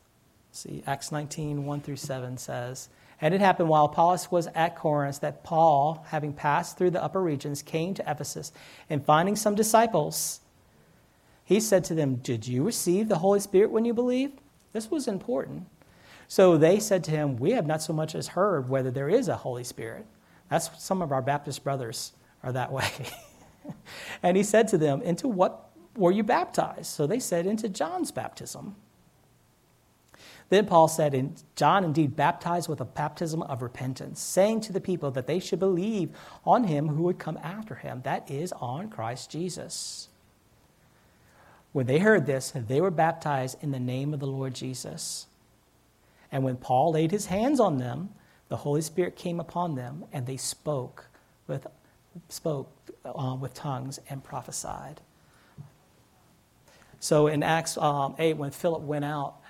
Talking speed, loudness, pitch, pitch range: 170 wpm, -27 LUFS, 160 Hz, 140-185 Hz